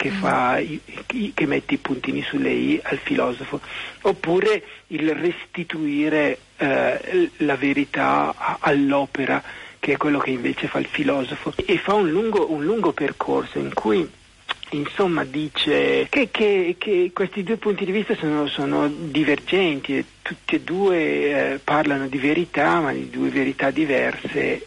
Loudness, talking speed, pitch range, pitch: -22 LUFS, 145 wpm, 140-195 Hz, 155 Hz